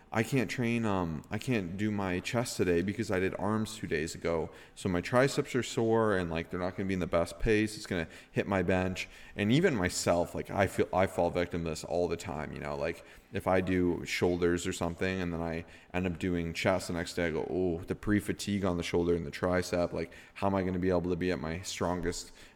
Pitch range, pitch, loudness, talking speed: 85-100 Hz, 90 Hz, -32 LUFS, 250 wpm